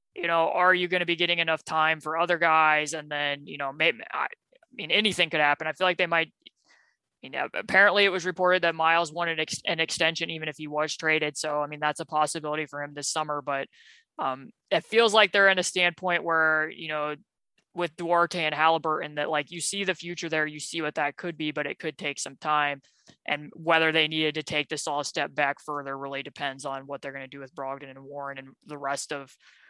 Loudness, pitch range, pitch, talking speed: -26 LUFS, 145-170 Hz, 155 Hz, 235 wpm